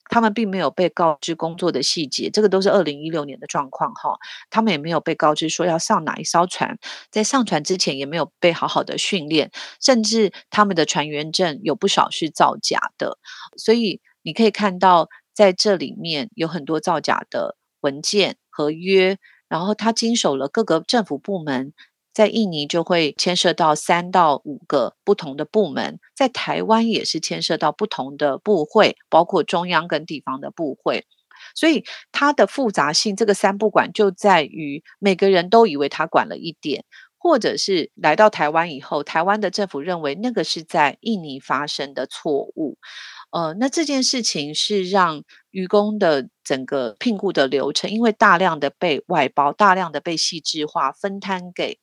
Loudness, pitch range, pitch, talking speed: -20 LUFS, 155-210 Hz, 180 Hz, 270 characters per minute